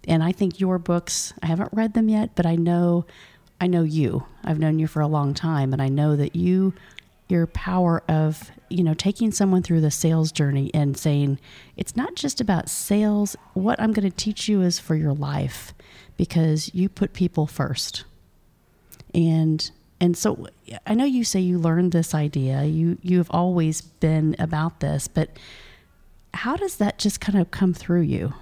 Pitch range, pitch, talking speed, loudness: 155-190 Hz, 170 Hz, 185 wpm, -23 LUFS